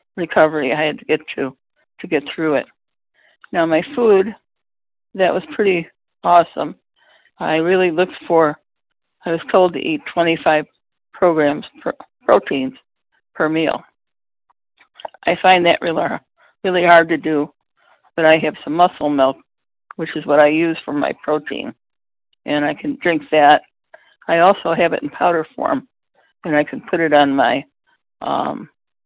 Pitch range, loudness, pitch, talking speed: 150-180 Hz, -17 LUFS, 160 Hz, 155 wpm